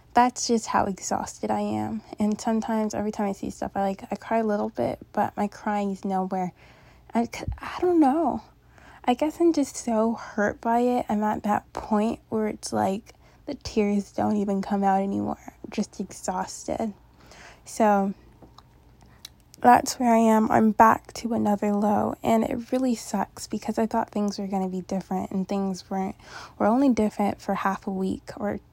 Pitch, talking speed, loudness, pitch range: 210 Hz, 185 wpm, -25 LUFS, 195-230 Hz